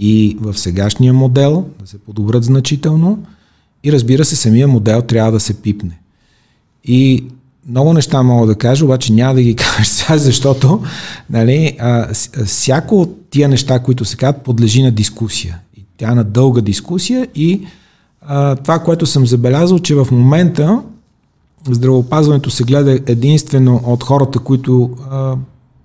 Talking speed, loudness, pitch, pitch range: 145 wpm, -12 LUFS, 130 Hz, 115-145 Hz